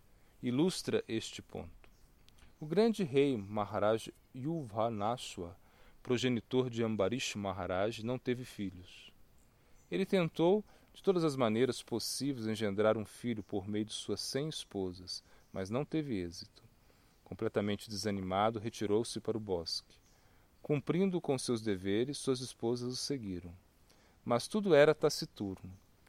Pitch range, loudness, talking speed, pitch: 100-130 Hz, -35 LUFS, 120 wpm, 110 Hz